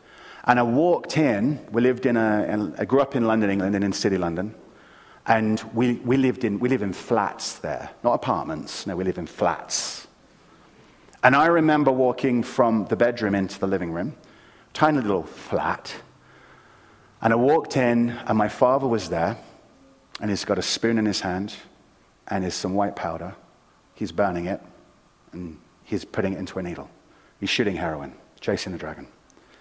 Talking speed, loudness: 180 wpm, -23 LUFS